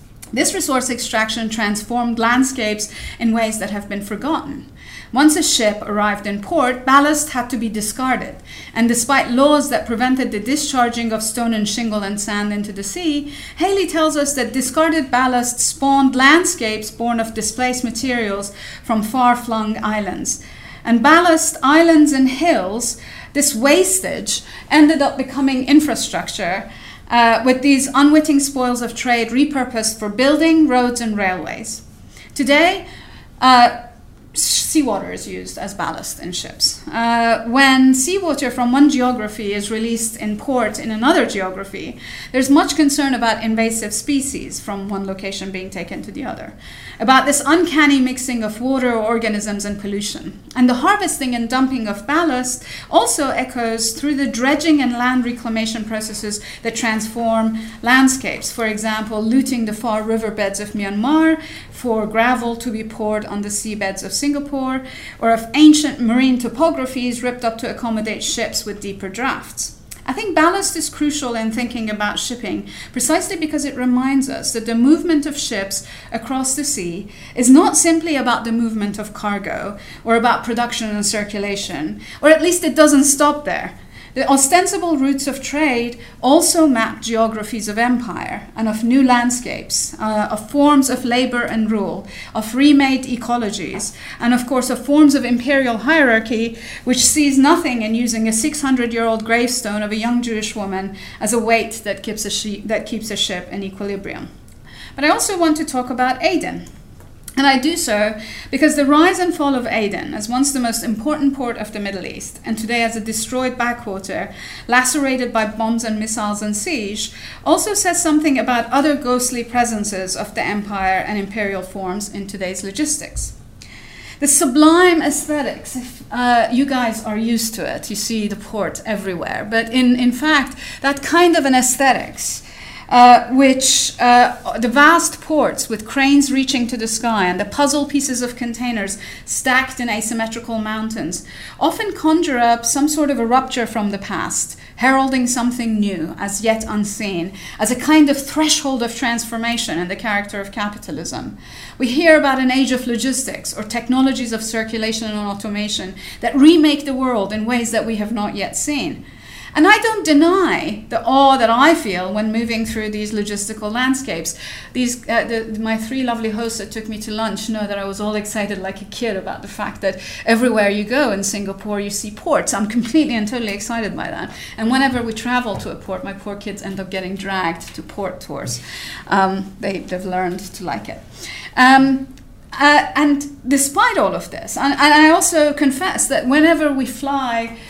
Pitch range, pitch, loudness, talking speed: 215-275 Hz, 240 Hz, -17 LUFS, 170 wpm